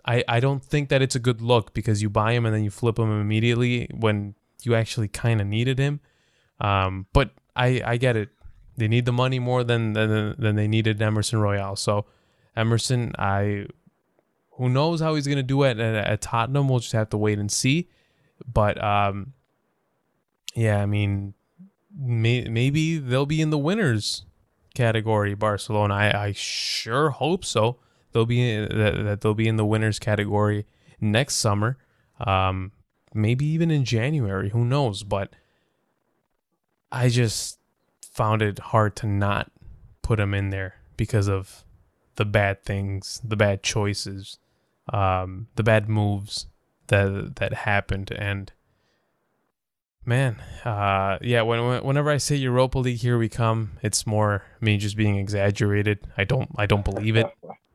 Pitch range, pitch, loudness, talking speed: 105-125 Hz, 110 Hz, -24 LUFS, 160 wpm